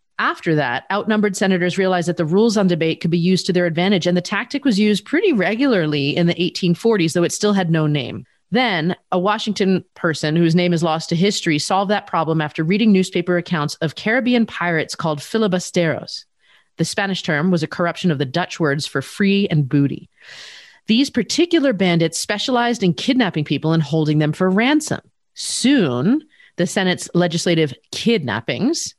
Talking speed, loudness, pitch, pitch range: 175 wpm, -18 LUFS, 180 Hz, 165-210 Hz